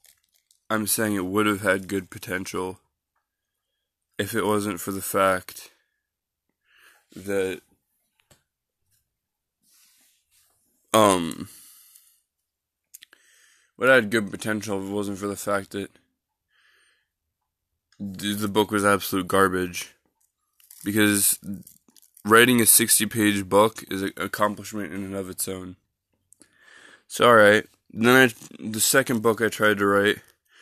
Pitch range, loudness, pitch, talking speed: 95-105 Hz, -22 LUFS, 100 Hz, 110 wpm